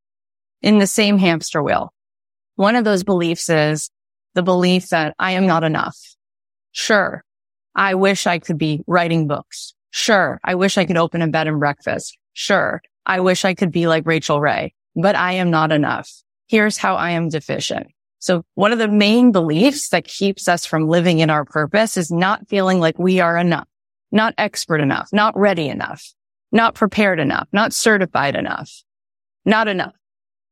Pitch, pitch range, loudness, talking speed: 175 Hz, 155-195 Hz, -17 LUFS, 175 wpm